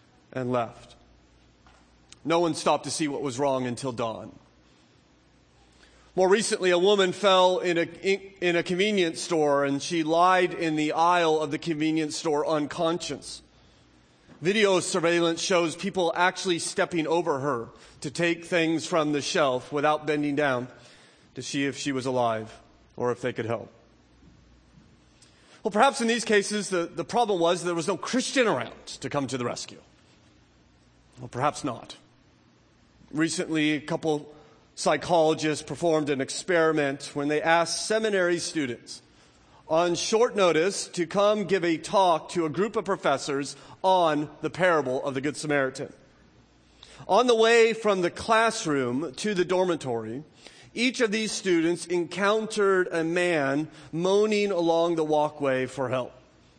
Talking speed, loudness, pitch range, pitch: 145 wpm, -25 LUFS, 140-180 Hz, 160 Hz